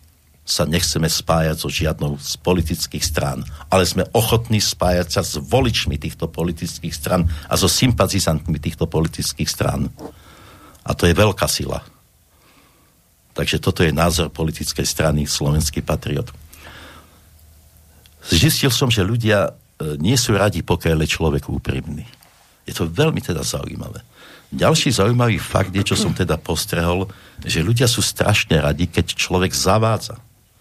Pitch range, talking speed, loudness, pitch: 80-100 Hz, 135 wpm, -19 LUFS, 85 Hz